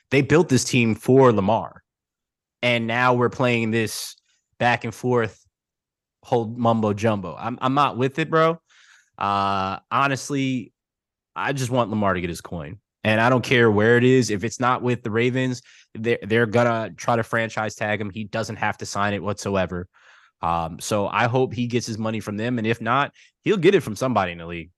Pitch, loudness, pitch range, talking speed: 115 Hz, -22 LUFS, 105-125 Hz, 200 wpm